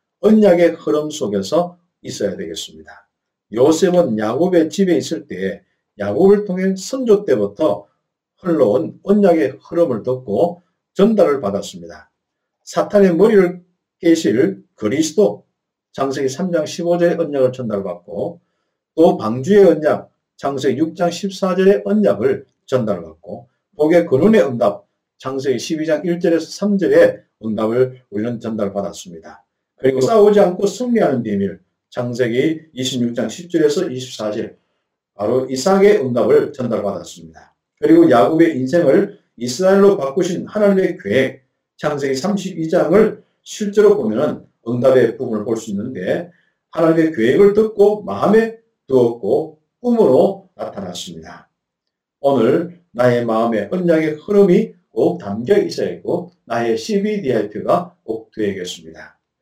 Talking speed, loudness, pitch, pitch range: 270 characters per minute, -16 LUFS, 165 Hz, 125-200 Hz